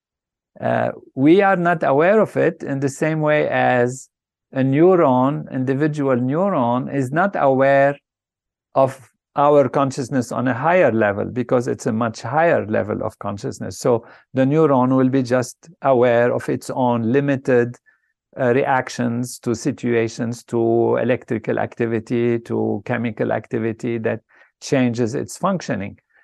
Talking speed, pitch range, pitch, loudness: 135 wpm, 120-140 Hz, 125 Hz, -19 LUFS